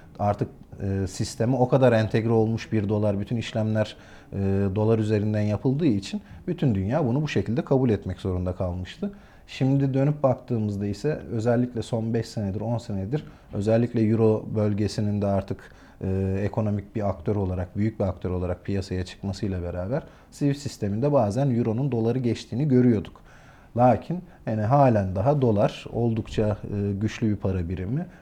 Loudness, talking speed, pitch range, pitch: -25 LUFS, 150 wpm, 100-125 Hz, 110 Hz